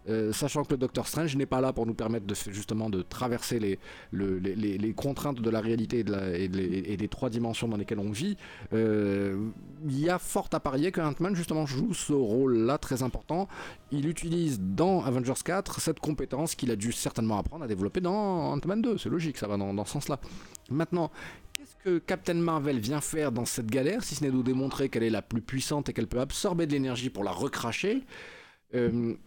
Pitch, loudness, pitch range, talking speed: 130 Hz, -30 LUFS, 110-155 Hz, 210 wpm